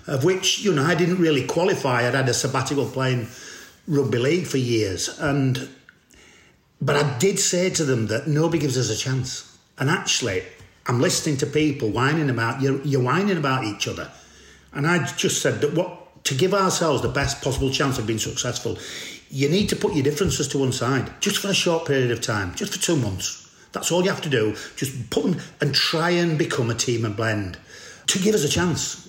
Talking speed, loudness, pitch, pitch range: 210 wpm, -22 LUFS, 140 Hz, 125-170 Hz